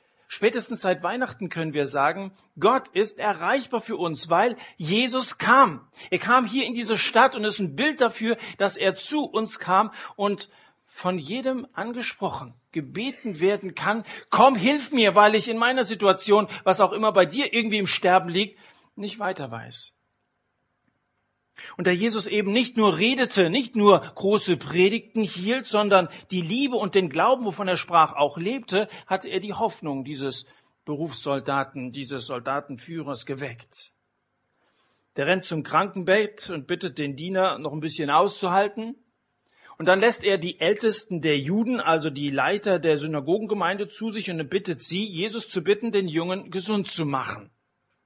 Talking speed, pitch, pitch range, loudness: 160 wpm, 195 Hz, 170-220 Hz, -23 LUFS